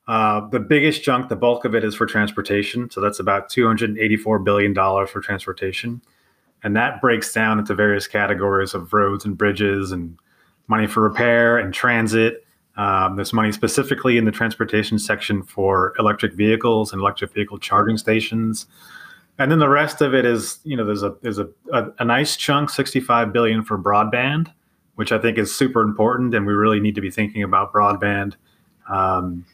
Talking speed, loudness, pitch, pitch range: 180 wpm, -19 LUFS, 110 Hz, 100-120 Hz